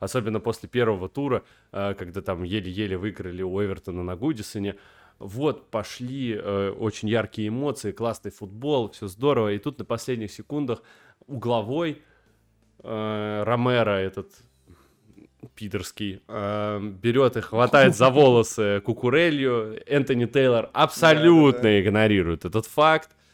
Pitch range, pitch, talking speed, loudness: 100-125 Hz, 110 Hz, 110 wpm, -23 LUFS